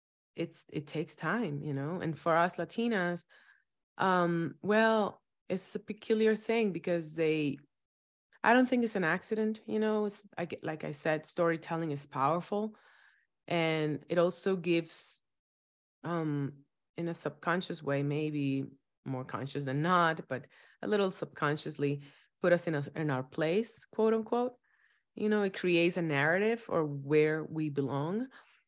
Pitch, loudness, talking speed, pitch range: 165 Hz, -32 LUFS, 150 wpm, 145-200 Hz